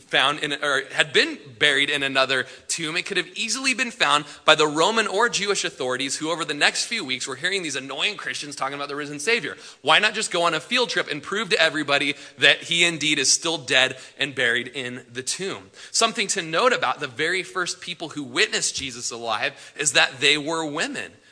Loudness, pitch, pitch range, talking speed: -21 LUFS, 155 Hz, 135-180 Hz, 215 wpm